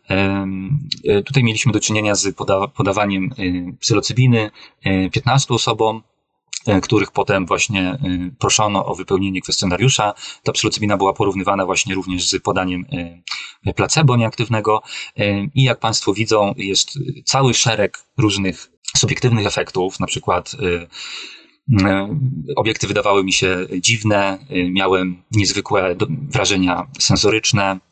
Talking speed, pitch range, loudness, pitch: 105 wpm, 95-115 Hz, -17 LUFS, 100 Hz